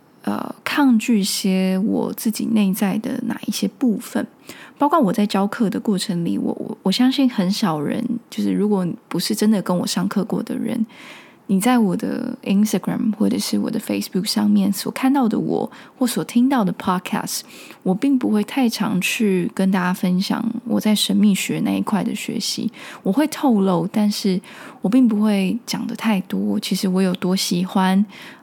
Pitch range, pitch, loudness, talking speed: 195-245 Hz, 215 Hz, -20 LUFS, 290 characters per minute